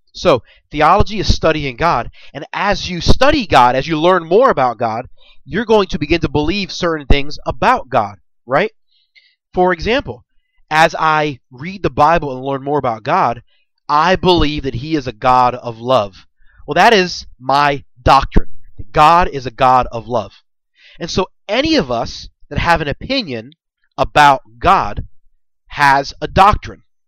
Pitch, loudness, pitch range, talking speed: 145 Hz, -14 LUFS, 125-170 Hz, 165 wpm